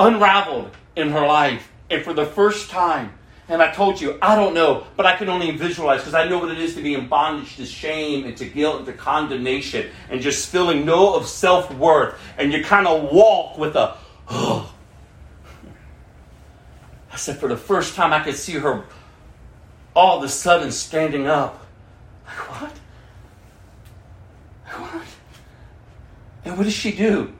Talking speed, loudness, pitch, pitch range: 170 wpm, -19 LUFS, 155 Hz, 140-180 Hz